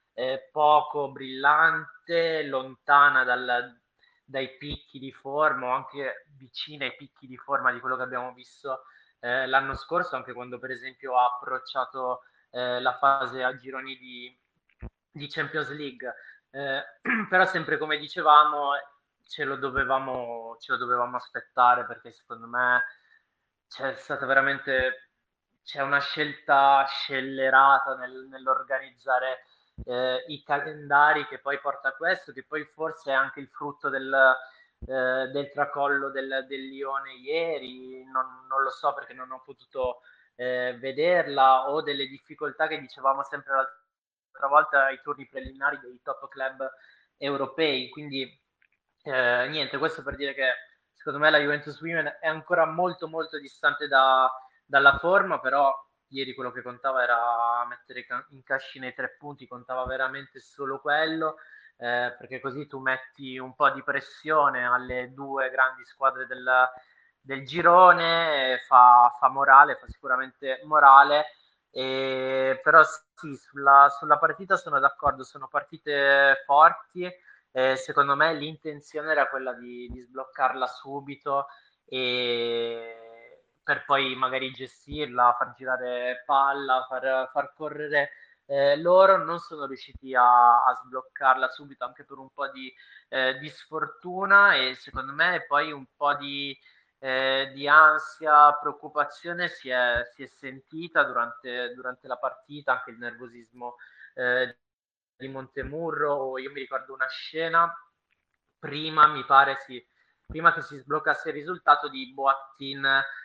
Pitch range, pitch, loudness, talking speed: 130-145 Hz, 135 Hz, -24 LUFS, 140 wpm